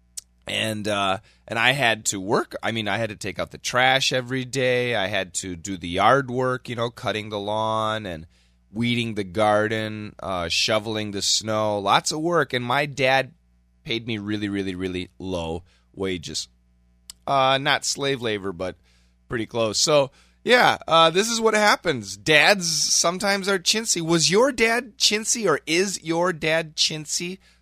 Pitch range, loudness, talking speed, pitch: 95-155 Hz, -22 LUFS, 170 wpm, 110 Hz